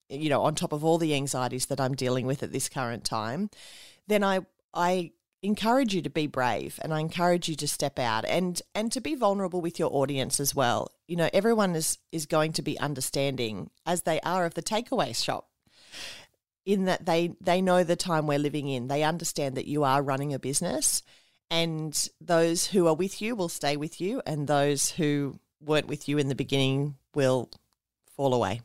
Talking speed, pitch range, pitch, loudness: 205 wpm, 140-175 Hz, 155 Hz, -28 LUFS